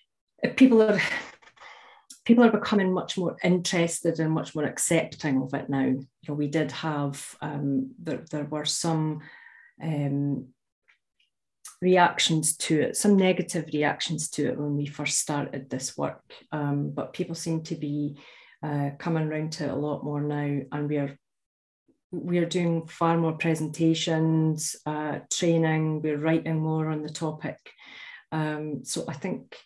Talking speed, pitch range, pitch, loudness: 150 wpm, 145-165 Hz, 155 Hz, -26 LUFS